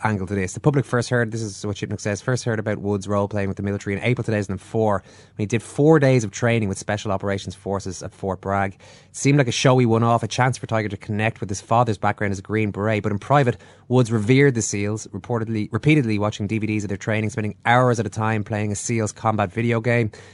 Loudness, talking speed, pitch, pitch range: -22 LUFS, 245 wpm, 110 Hz, 100-115 Hz